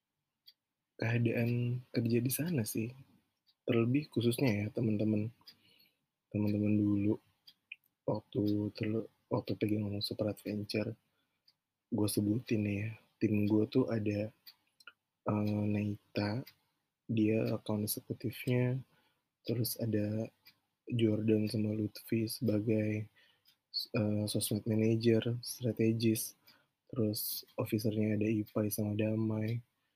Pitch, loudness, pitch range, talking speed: 110 Hz, -35 LUFS, 105-115 Hz, 95 wpm